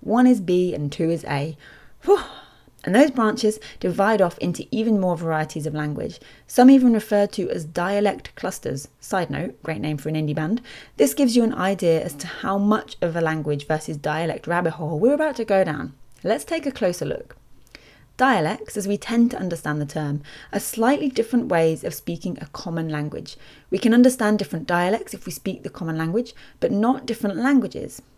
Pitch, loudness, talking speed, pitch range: 185 Hz, -22 LUFS, 195 wpm, 155-230 Hz